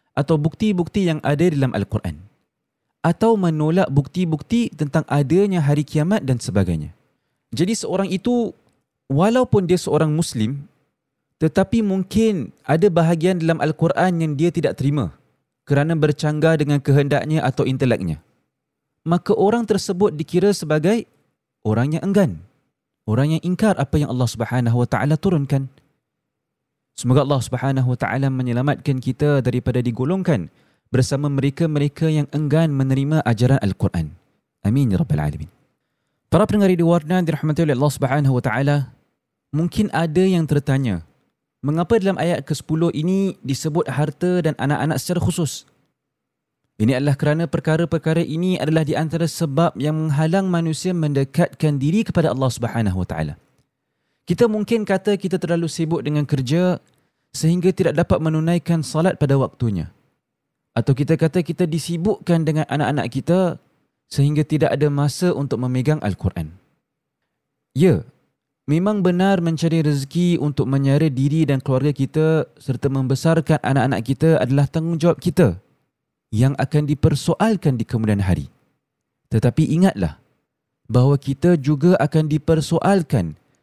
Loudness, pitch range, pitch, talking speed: -19 LUFS, 135-170 Hz, 155 Hz, 130 wpm